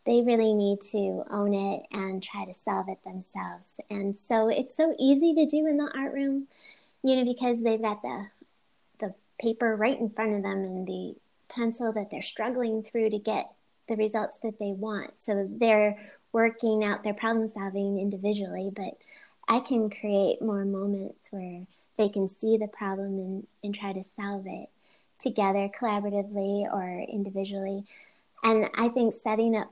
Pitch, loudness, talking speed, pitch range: 210 Hz, -29 LUFS, 170 wpm, 200-230 Hz